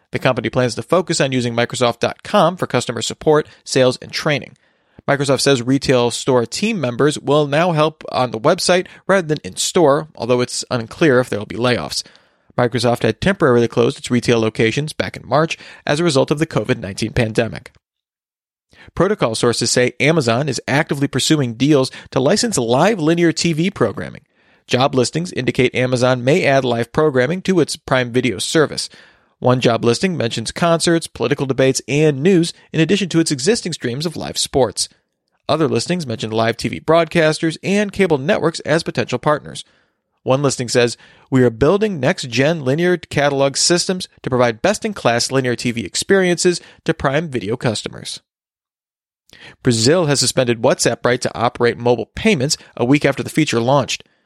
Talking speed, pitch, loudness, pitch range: 165 wpm, 140 Hz, -17 LUFS, 125-165 Hz